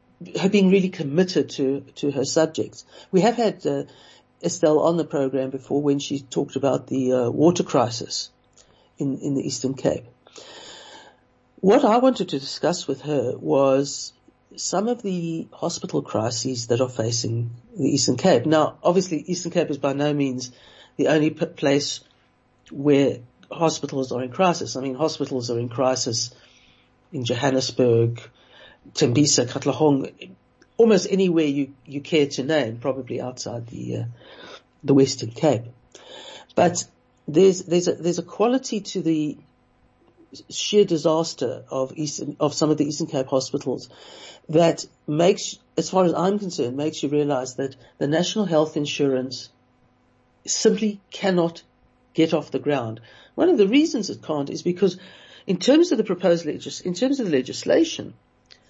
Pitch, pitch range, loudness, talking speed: 145 Hz, 130-175 Hz, -22 LUFS, 155 wpm